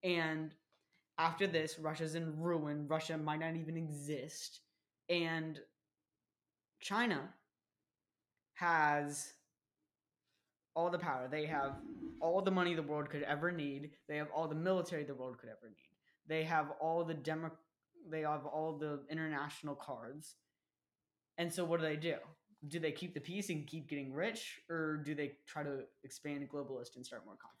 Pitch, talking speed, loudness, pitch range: 155 Hz, 160 wpm, -40 LUFS, 145-165 Hz